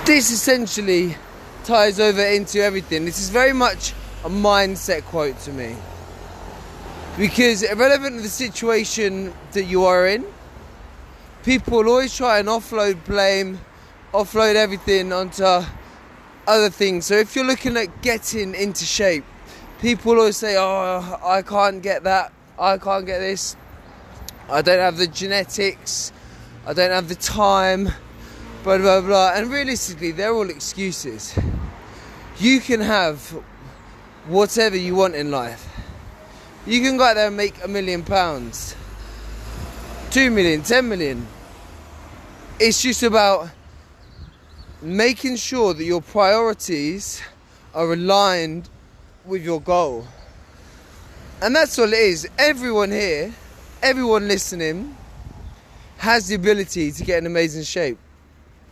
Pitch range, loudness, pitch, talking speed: 155-215 Hz, -19 LUFS, 190 Hz, 130 wpm